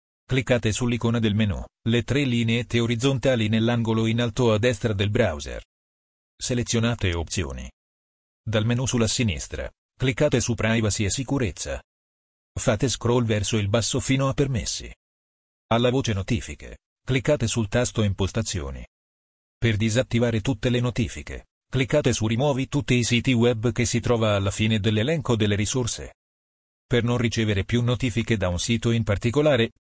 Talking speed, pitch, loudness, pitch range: 145 wpm, 115 Hz, -23 LUFS, 95-120 Hz